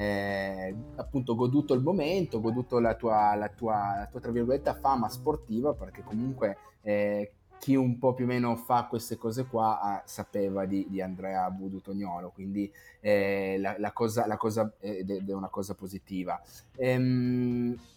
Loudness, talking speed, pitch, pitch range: -30 LUFS, 170 wpm, 110 Hz, 100-125 Hz